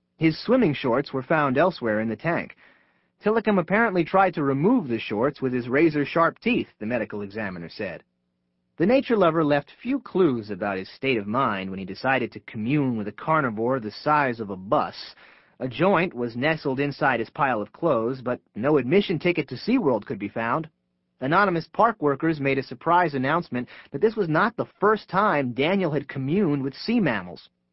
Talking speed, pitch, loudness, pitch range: 190 wpm, 145 Hz, -24 LUFS, 120-180 Hz